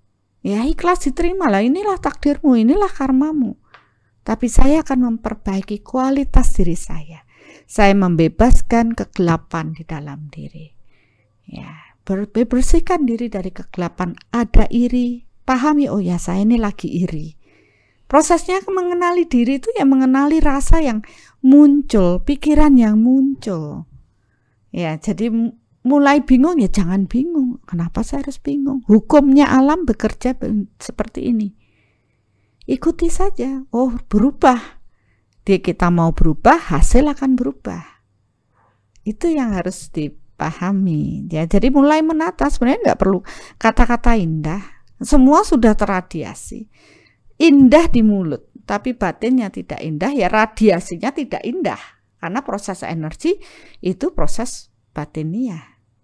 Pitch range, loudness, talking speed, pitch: 180-275 Hz, -17 LUFS, 115 wpm, 230 Hz